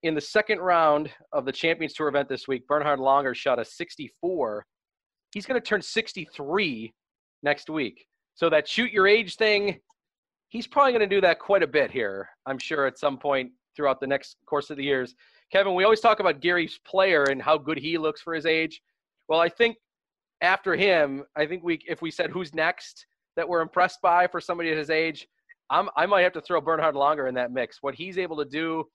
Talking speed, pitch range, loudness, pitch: 215 wpm, 145-190 Hz, -25 LUFS, 160 Hz